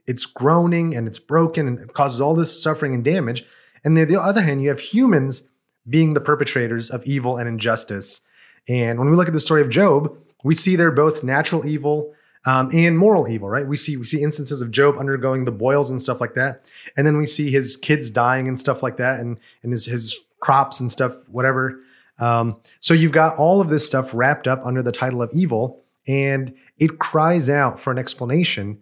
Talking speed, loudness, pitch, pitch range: 215 wpm, -19 LUFS, 135 Hz, 125-155 Hz